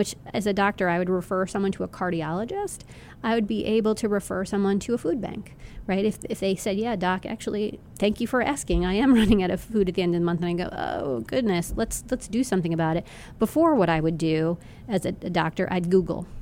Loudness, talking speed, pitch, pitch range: -25 LUFS, 250 wpm, 195 Hz, 180-220 Hz